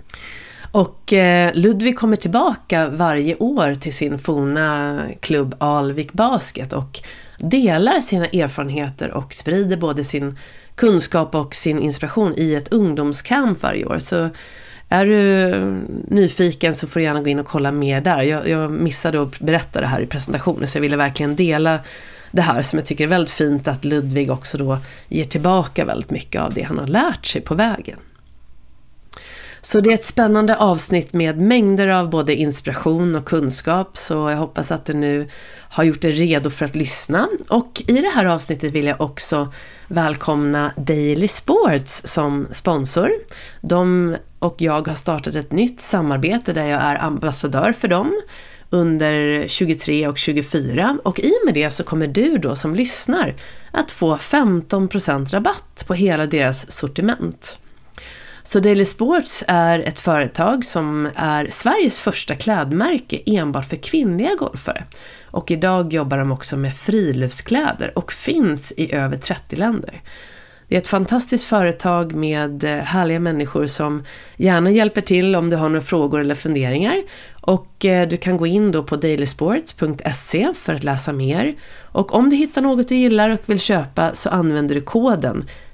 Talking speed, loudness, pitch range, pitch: 160 wpm, -18 LUFS, 150-195 Hz, 160 Hz